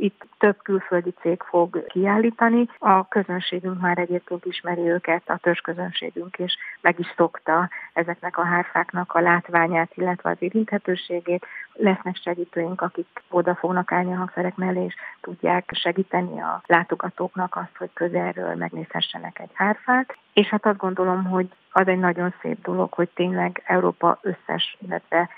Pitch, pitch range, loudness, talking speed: 180 Hz, 175-190 Hz, -23 LUFS, 145 wpm